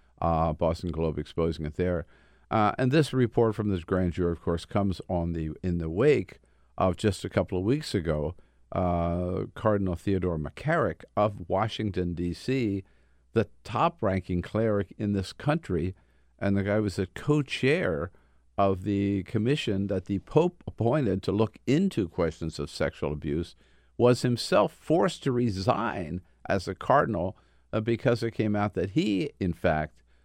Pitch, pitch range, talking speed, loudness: 95 Hz, 85-110 Hz, 160 wpm, -28 LUFS